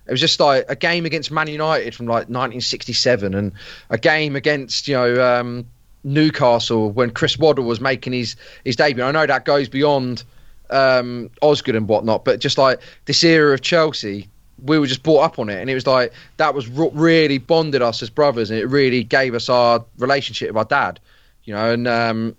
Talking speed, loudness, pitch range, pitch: 205 wpm, -17 LUFS, 120-145 Hz, 130 Hz